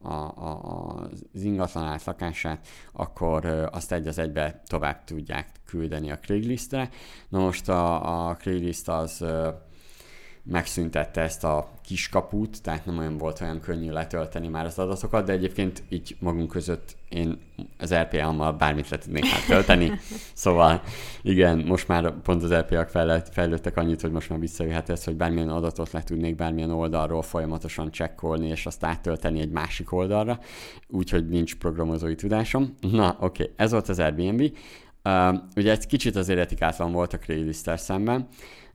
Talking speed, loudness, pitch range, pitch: 145 wpm, -26 LUFS, 80-90 Hz, 85 Hz